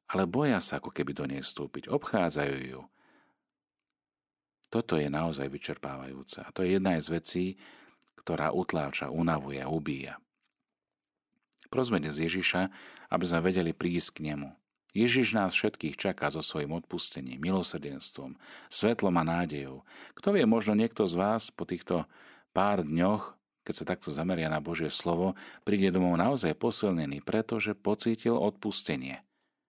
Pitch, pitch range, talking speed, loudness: 85 Hz, 70-95 Hz, 135 wpm, -30 LUFS